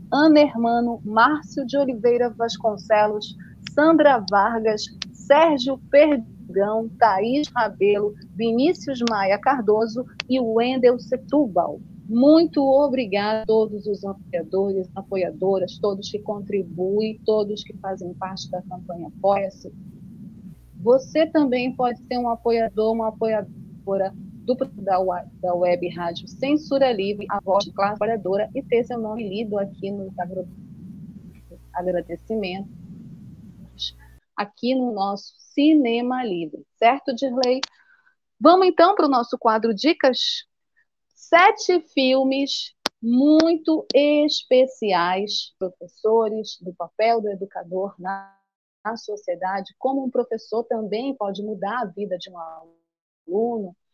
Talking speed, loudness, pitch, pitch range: 110 wpm, -21 LUFS, 215 Hz, 195-255 Hz